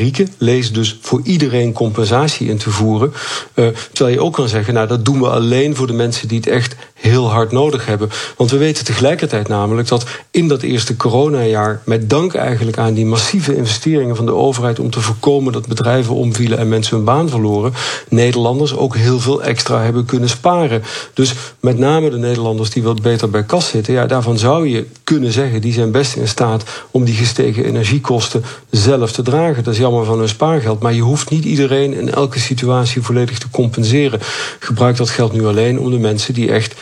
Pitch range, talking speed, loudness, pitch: 115-135 Hz, 200 wpm, -14 LUFS, 120 Hz